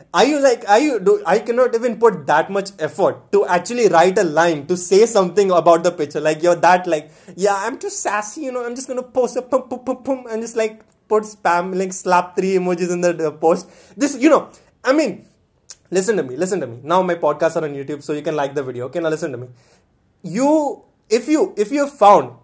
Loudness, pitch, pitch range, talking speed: -18 LUFS, 190 Hz, 170-245 Hz, 245 wpm